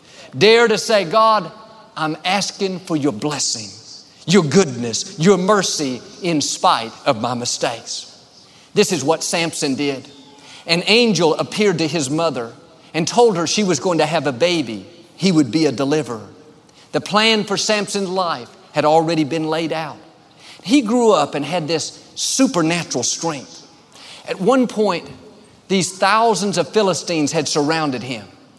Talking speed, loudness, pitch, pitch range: 150 wpm, -17 LUFS, 165 Hz, 150-195 Hz